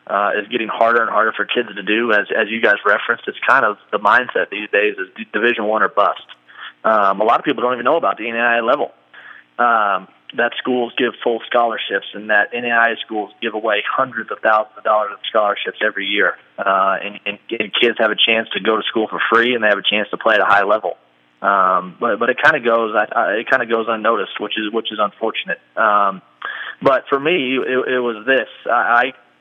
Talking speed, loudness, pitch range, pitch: 235 wpm, -17 LUFS, 105-120 Hz, 115 Hz